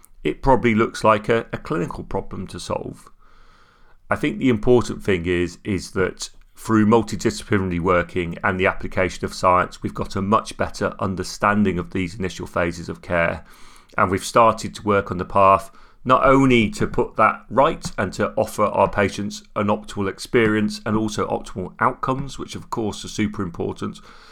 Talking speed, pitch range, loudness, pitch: 175 wpm, 90-110 Hz, -21 LUFS, 100 Hz